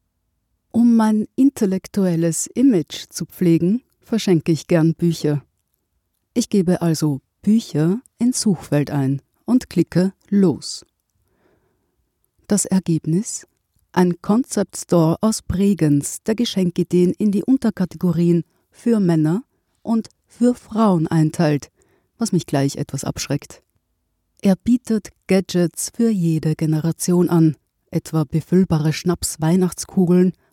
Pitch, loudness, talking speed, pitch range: 175 Hz, -19 LUFS, 105 wpm, 155-205 Hz